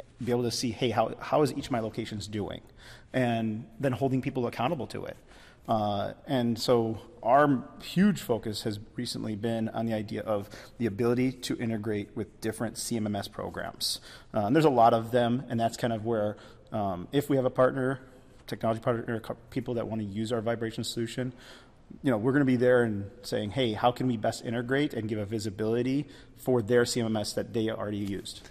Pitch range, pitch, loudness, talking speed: 110-125 Hz, 115 Hz, -29 LUFS, 200 wpm